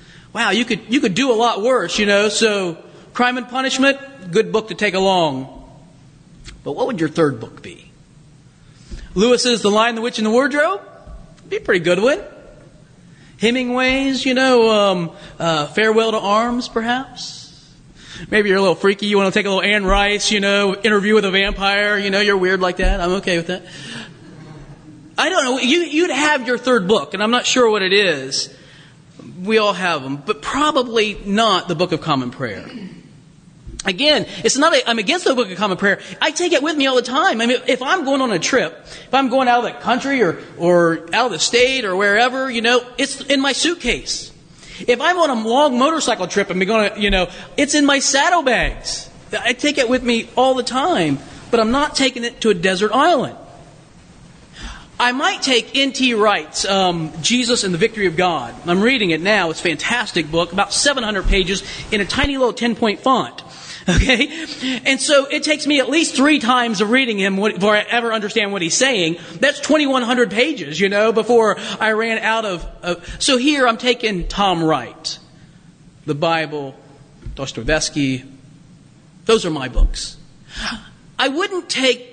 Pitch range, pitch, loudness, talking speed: 175-255 Hz, 215 Hz, -17 LUFS, 195 wpm